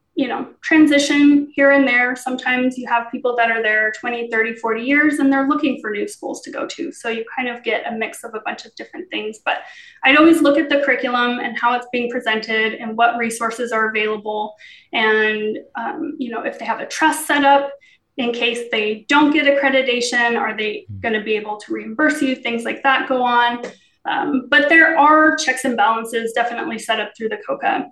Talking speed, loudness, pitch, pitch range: 215 wpm, -17 LUFS, 245 Hz, 225-285 Hz